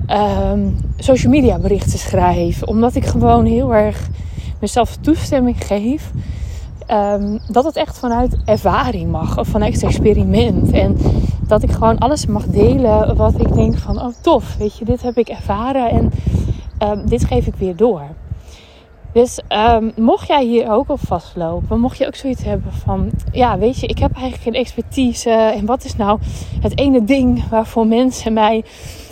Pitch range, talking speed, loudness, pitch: 175-250 Hz, 170 wpm, -15 LUFS, 225 Hz